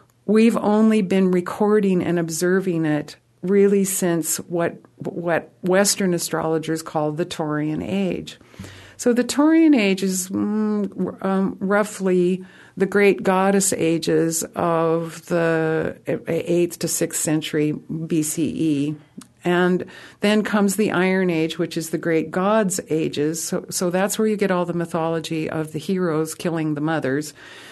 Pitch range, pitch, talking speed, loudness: 160-195 Hz, 175 Hz, 135 wpm, -21 LUFS